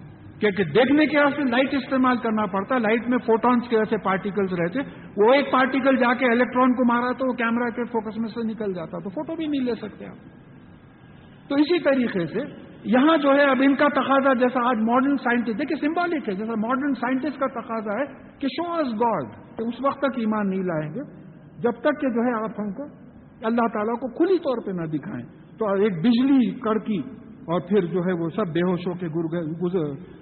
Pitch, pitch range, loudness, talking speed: 235 Hz, 205-270 Hz, -23 LUFS, 205 wpm